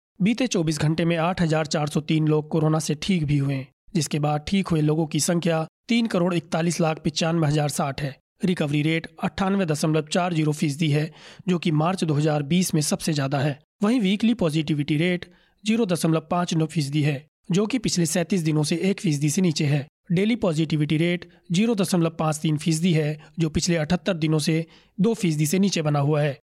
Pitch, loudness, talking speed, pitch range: 165 Hz, -23 LUFS, 180 wpm, 155-180 Hz